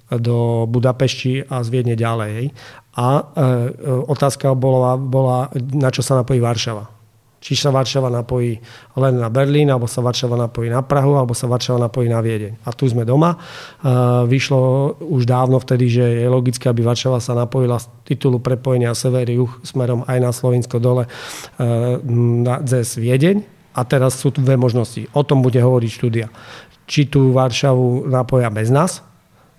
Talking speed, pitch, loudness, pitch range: 155 wpm, 125 Hz, -17 LUFS, 120-135 Hz